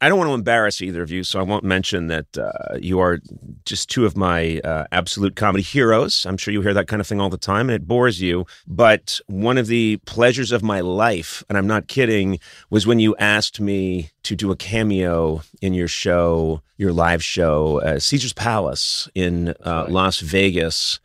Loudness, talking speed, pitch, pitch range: -19 LUFS, 210 wpm, 95 Hz, 85-105 Hz